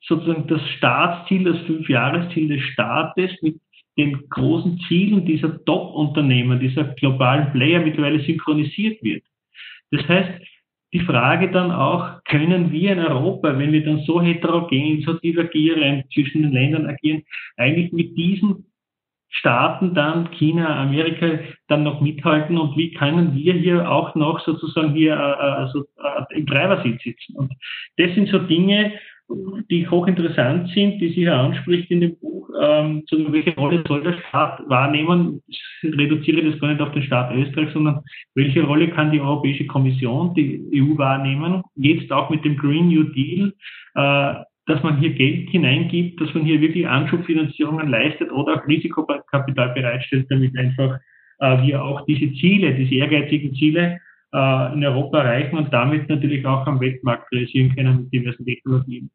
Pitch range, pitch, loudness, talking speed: 140-170 Hz, 155 Hz, -19 LUFS, 155 wpm